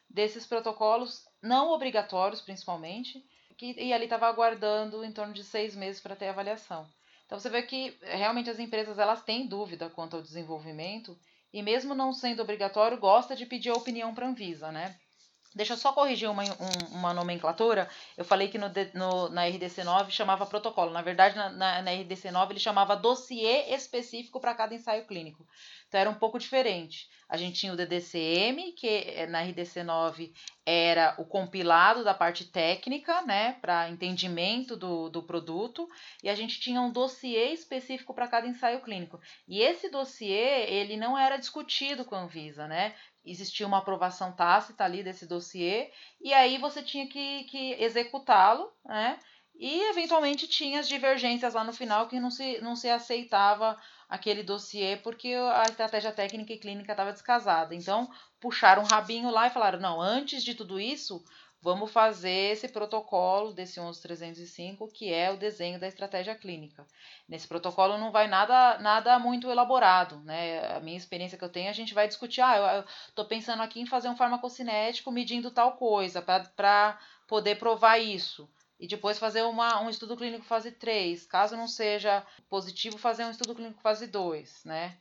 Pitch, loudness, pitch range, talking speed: 210 Hz, -29 LUFS, 185-240 Hz, 170 wpm